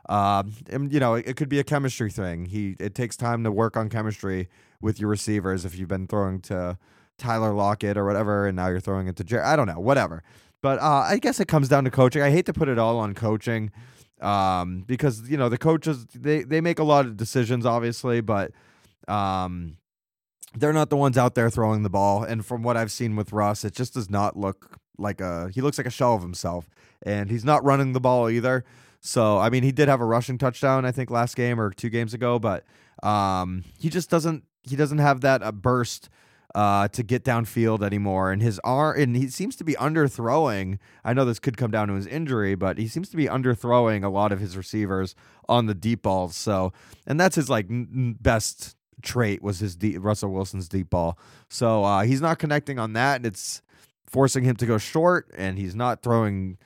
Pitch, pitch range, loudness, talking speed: 115 Hz, 100-130 Hz, -24 LUFS, 220 wpm